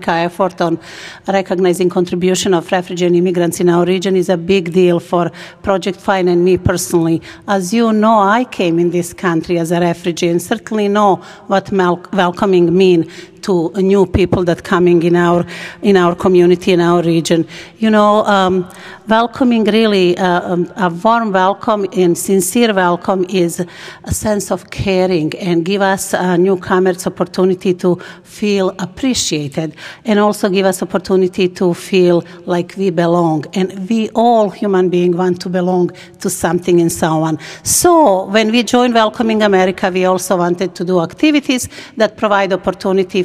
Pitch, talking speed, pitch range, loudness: 185 Hz, 160 wpm, 175-200 Hz, -14 LUFS